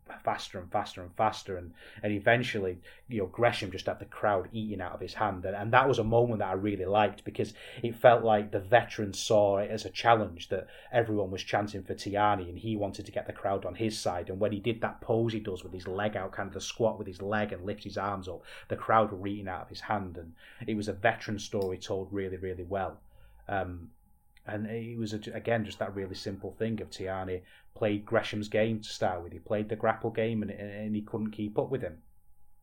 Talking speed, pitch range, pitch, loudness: 235 wpm, 95-110 Hz, 105 Hz, -31 LUFS